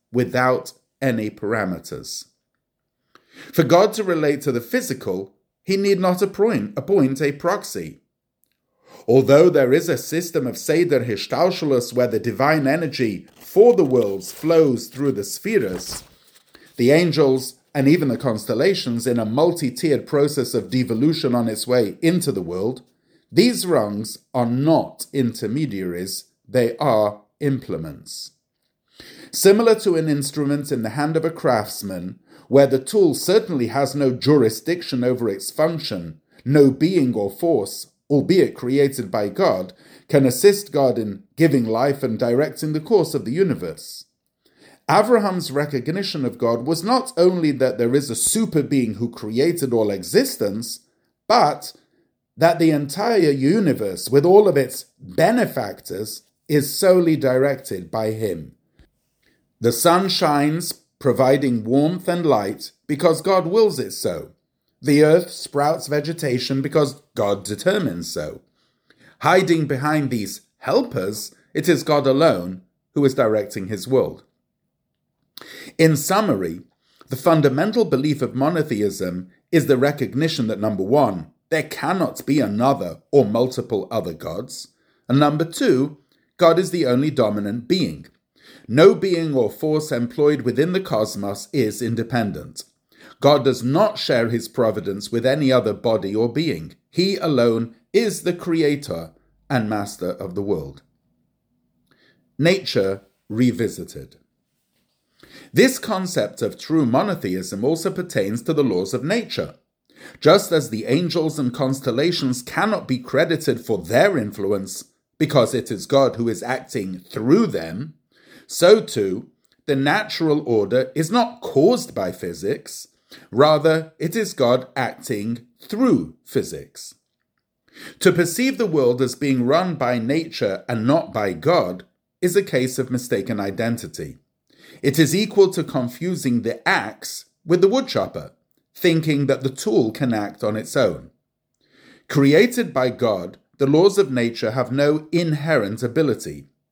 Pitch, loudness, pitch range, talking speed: 140 Hz, -20 LUFS, 120-165 Hz, 135 wpm